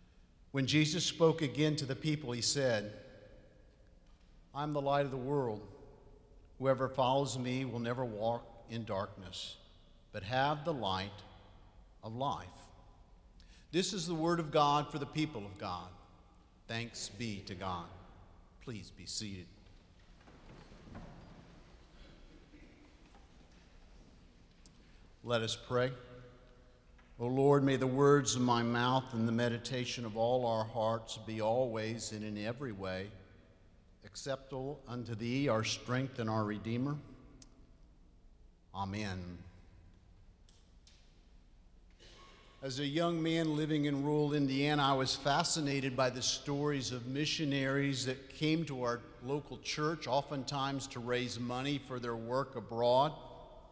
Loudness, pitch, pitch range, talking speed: -35 LUFS, 120 Hz, 95-135 Hz, 125 wpm